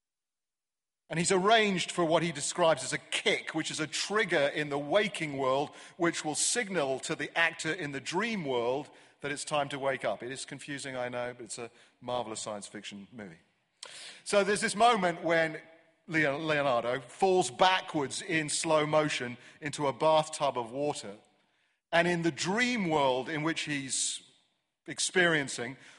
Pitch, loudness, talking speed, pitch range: 155 Hz, -30 LUFS, 165 wpm, 135-170 Hz